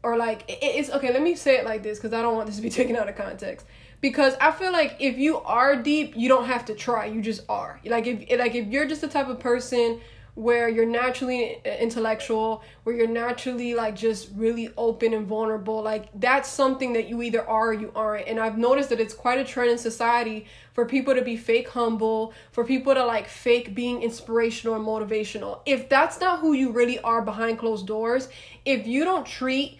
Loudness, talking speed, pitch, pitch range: -24 LUFS, 220 wpm, 235 Hz, 225-260 Hz